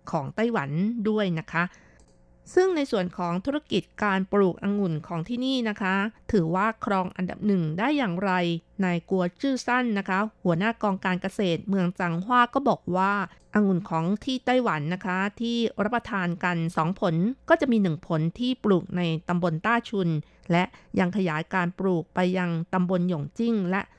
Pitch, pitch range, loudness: 190 Hz, 175-220 Hz, -26 LUFS